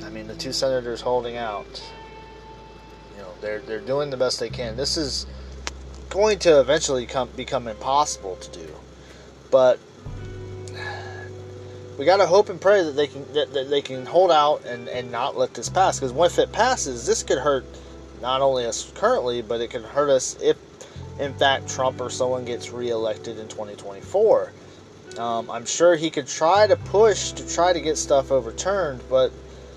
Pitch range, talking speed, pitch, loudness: 110-150 Hz, 170 wpm, 130 Hz, -22 LUFS